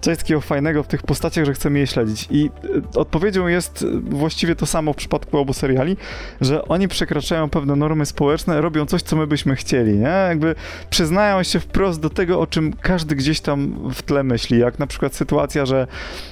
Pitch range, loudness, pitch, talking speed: 140-170 Hz, -19 LUFS, 155 Hz, 190 wpm